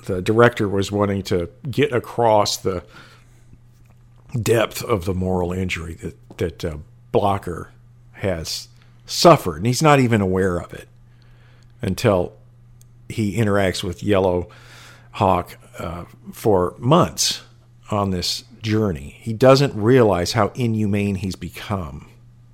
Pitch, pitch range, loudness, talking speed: 110 Hz, 95-120 Hz, -20 LUFS, 120 wpm